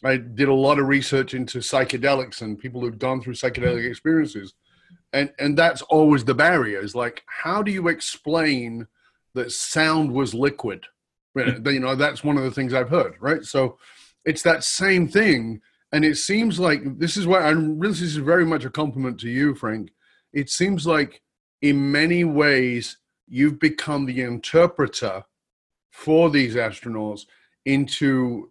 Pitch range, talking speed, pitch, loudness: 130-160 Hz, 165 wpm, 140 Hz, -21 LUFS